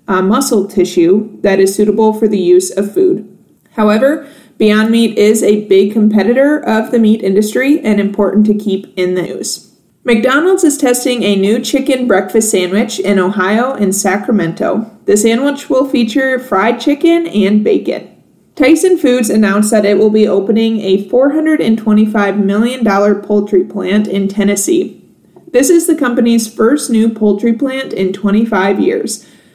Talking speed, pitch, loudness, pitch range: 150 wpm, 215 Hz, -11 LUFS, 200-250 Hz